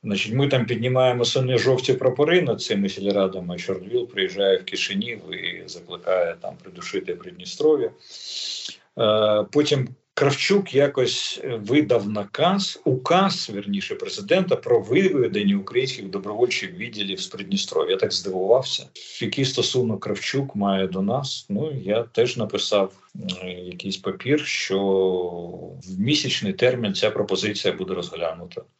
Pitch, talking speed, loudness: 135 Hz, 120 wpm, -23 LUFS